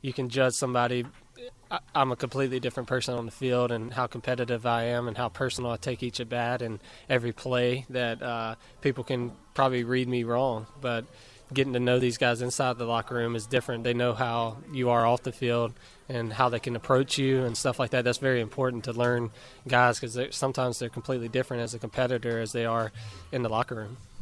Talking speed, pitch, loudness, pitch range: 215 wpm, 125 Hz, -29 LUFS, 120-130 Hz